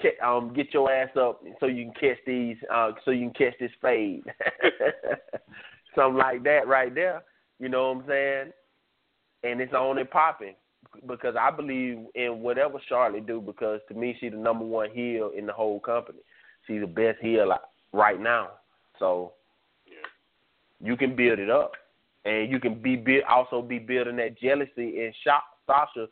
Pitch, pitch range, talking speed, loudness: 120 Hz, 115-130 Hz, 170 wpm, -26 LUFS